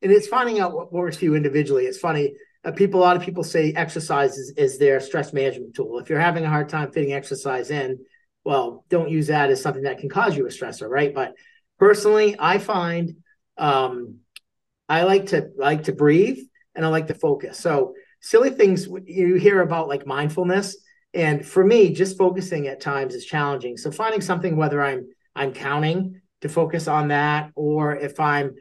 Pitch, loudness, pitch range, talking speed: 165 Hz, -21 LUFS, 145-195 Hz, 195 wpm